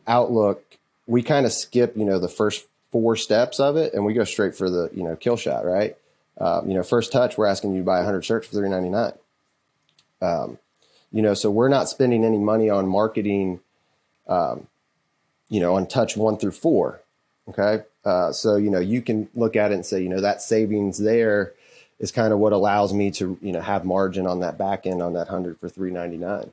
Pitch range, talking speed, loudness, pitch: 95-110 Hz, 215 wpm, -22 LUFS, 100 Hz